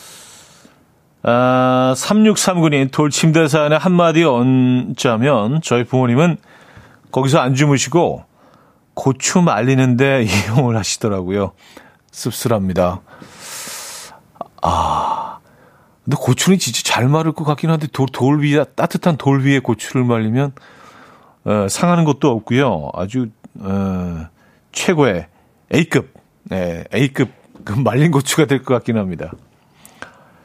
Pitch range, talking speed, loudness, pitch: 115-150 Hz, 225 characters per minute, -16 LUFS, 130 Hz